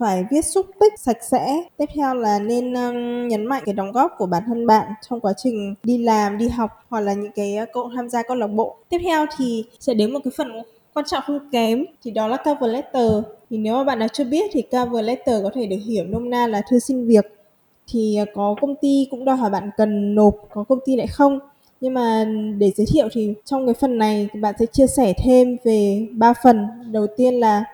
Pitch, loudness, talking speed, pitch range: 235 Hz, -20 LUFS, 240 wpm, 215-260 Hz